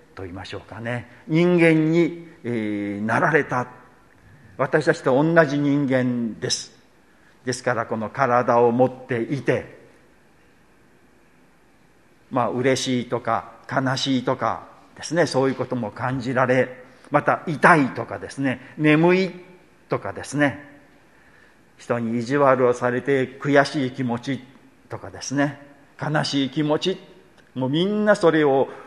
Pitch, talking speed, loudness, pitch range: 130 Hz, 240 characters per minute, -21 LUFS, 120-145 Hz